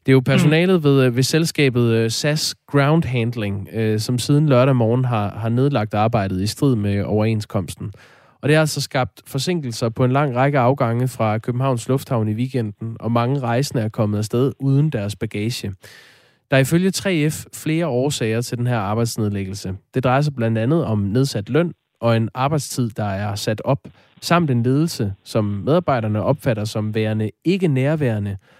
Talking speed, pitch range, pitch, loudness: 170 wpm, 110-140 Hz, 125 Hz, -19 LUFS